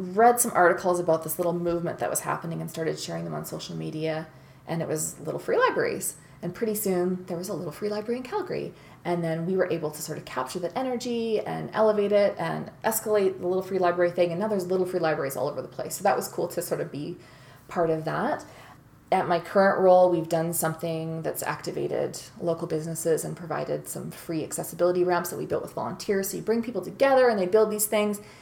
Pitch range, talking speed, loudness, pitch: 160-210 Hz, 230 wpm, -26 LUFS, 175 Hz